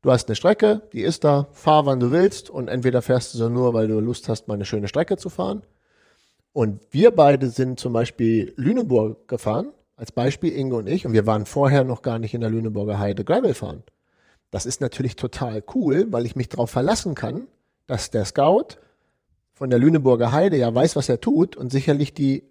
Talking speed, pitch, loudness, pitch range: 210 wpm, 125 Hz, -21 LUFS, 115-145 Hz